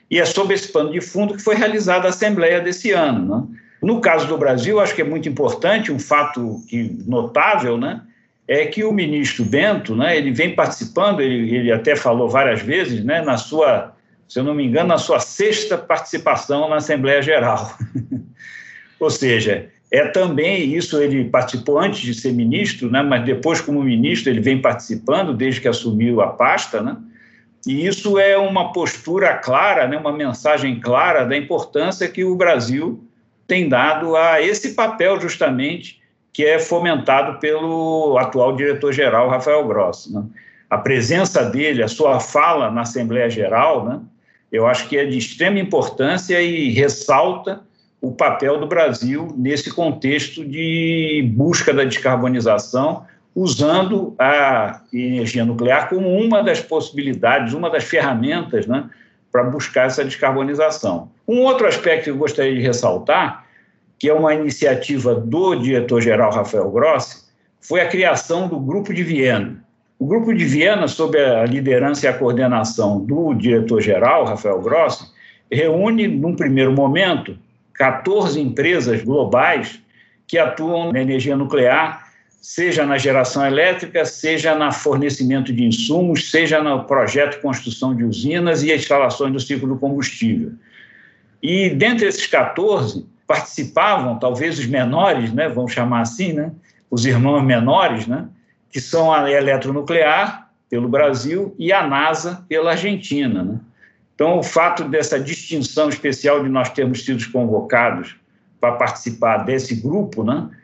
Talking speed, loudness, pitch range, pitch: 150 wpm, -17 LUFS, 130-170 Hz, 145 Hz